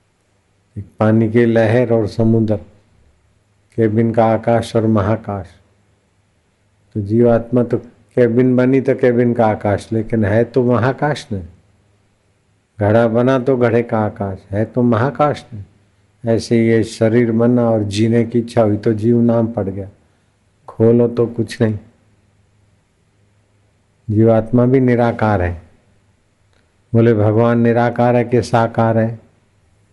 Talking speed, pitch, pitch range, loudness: 130 wpm, 110 Hz, 100-120 Hz, -15 LUFS